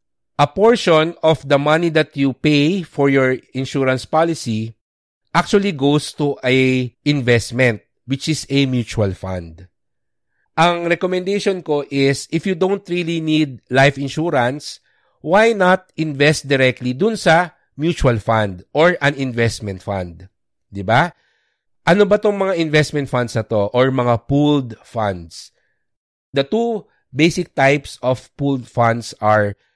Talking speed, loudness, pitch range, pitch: 135 wpm, -17 LUFS, 120-165 Hz, 140 Hz